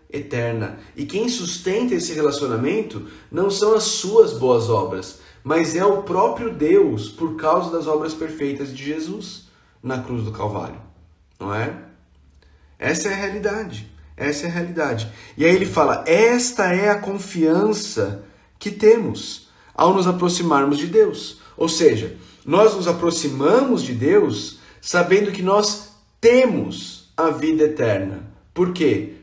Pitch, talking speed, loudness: 160 Hz, 140 wpm, -19 LUFS